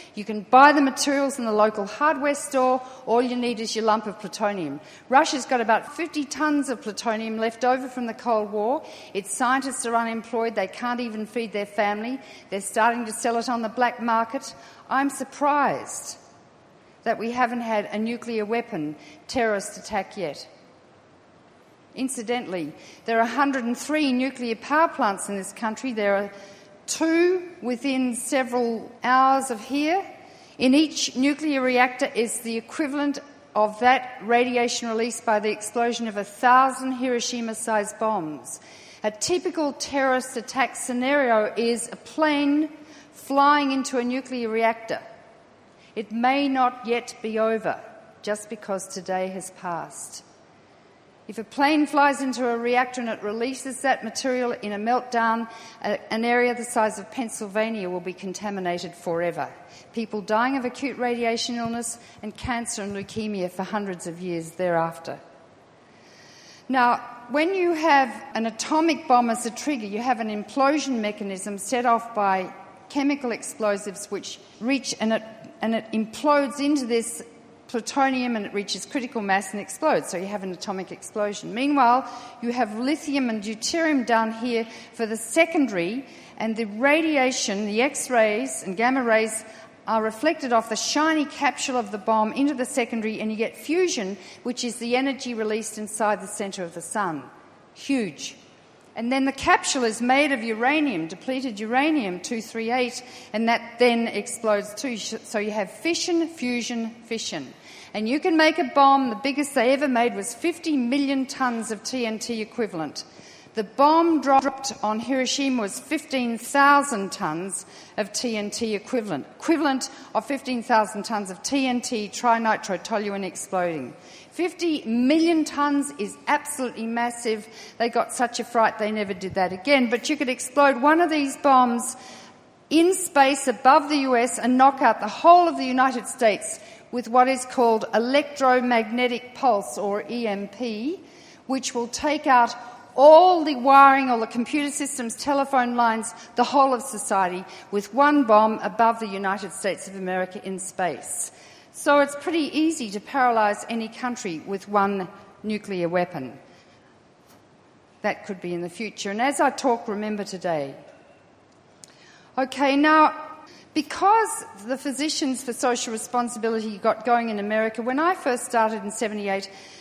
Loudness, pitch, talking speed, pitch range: -23 LUFS, 235 Hz, 150 wpm, 215-270 Hz